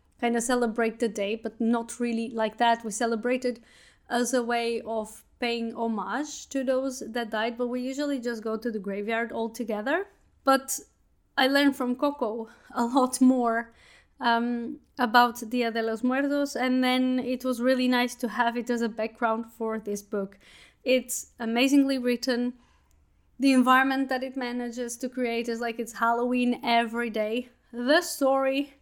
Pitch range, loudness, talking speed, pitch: 230-255 Hz, -27 LUFS, 165 wpm, 240 Hz